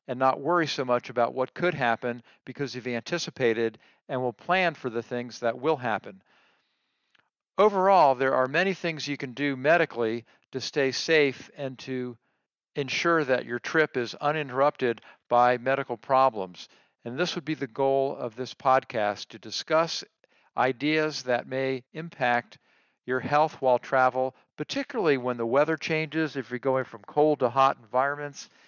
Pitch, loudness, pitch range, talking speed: 130 Hz, -26 LUFS, 125-150 Hz, 160 wpm